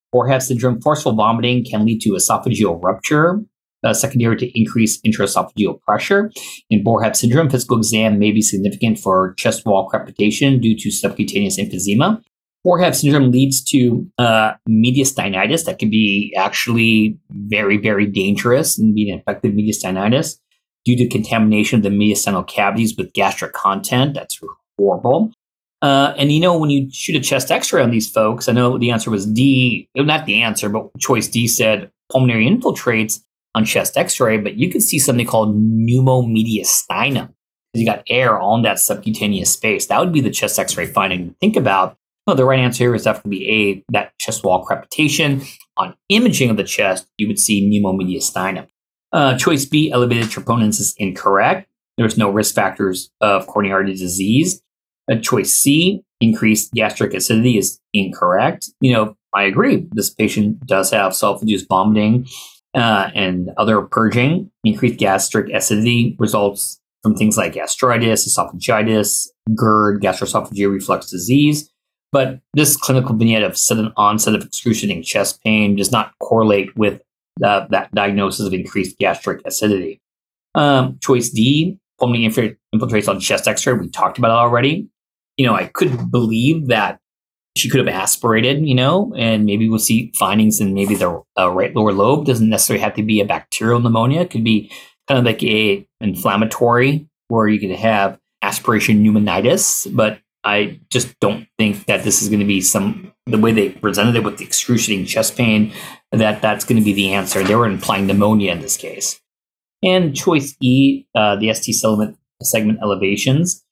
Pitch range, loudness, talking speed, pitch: 105-130 Hz, -16 LUFS, 165 wpm, 110 Hz